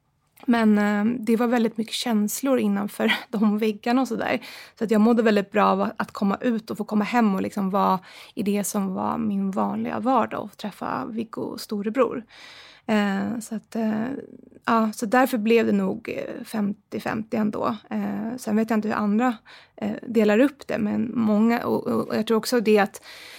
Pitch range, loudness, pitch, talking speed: 210-235 Hz, -24 LUFS, 220 Hz, 190 wpm